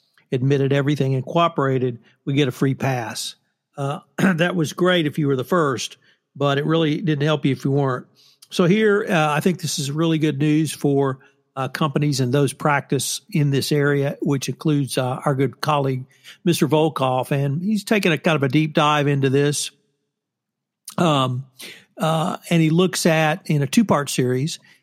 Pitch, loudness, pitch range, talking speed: 145 Hz, -20 LUFS, 140-160 Hz, 185 wpm